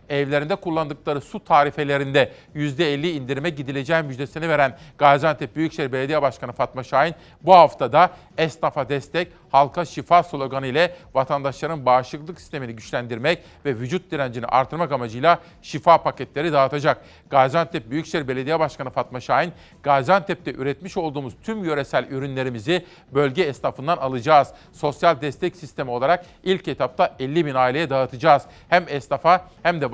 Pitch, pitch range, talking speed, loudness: 150 Hz, 135-170 Hz, 130 wpm, -21 LUFS